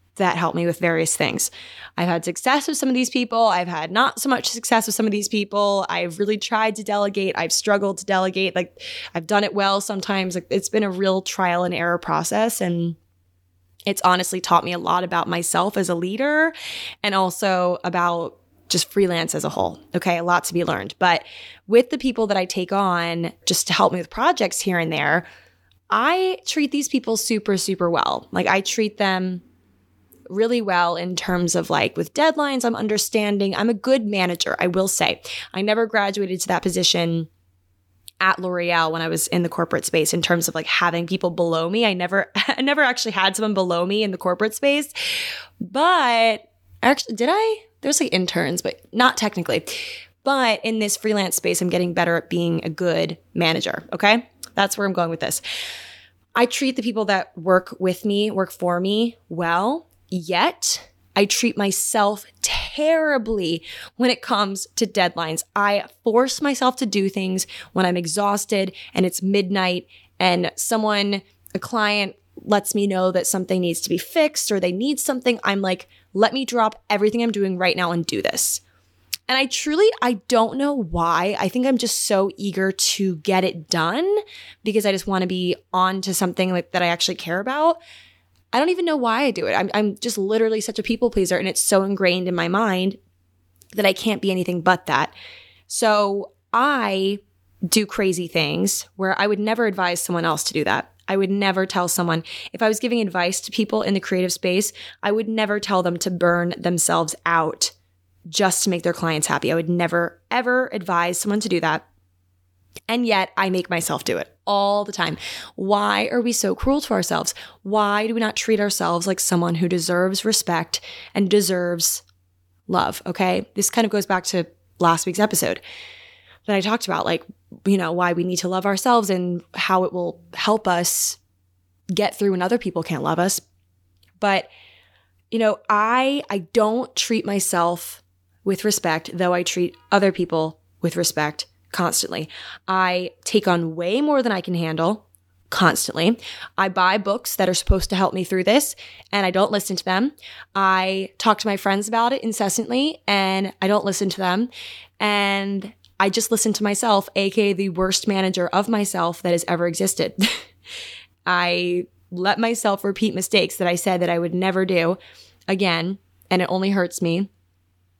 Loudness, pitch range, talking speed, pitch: -21 LUFS, 175-215 Hz, 190 wpm, 190 Hz